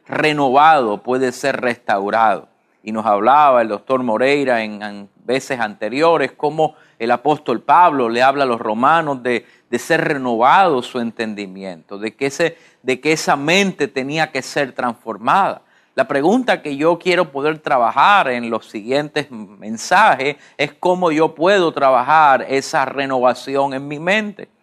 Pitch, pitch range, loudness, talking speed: 140 Hz, 120-155 Hz, -16 LUFS, 150 wpm